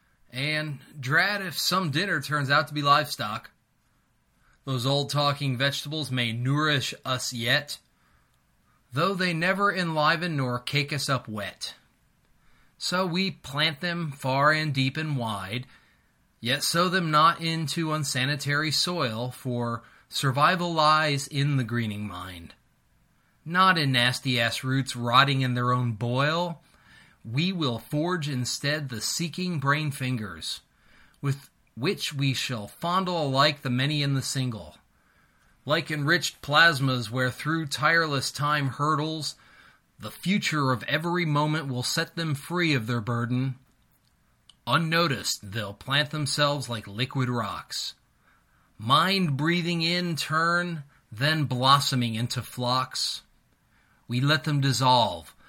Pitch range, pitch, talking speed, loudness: 125-155 Hz, 140 Hz, 125 wpm, -26 LUFS